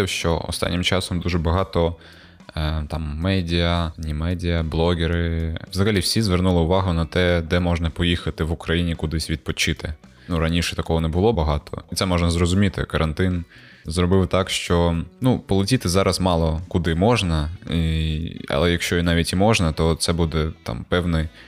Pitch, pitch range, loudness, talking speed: 85 Hz, 80-90 Hz, -21 LUFS, 155 wpm